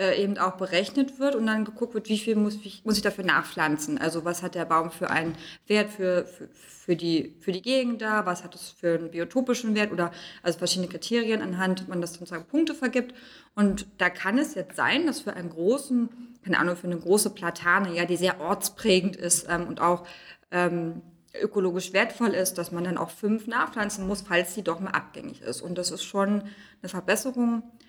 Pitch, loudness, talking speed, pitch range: 190 Hz, -27 LUFS, 210 wpm, 175-215 Hz